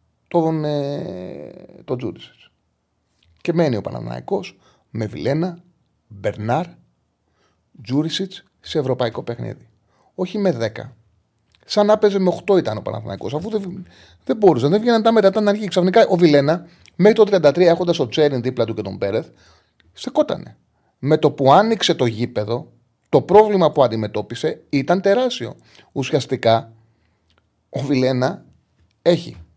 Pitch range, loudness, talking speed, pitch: 115-185 Hz, -19 LUFS, 135 wpm, 145 Hz